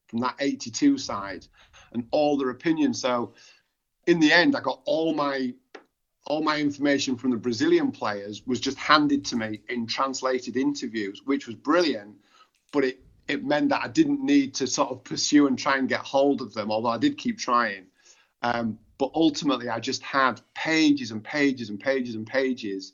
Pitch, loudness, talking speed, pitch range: 135 Hz, -25 LUFS, 185 wpm, 120-155 Hz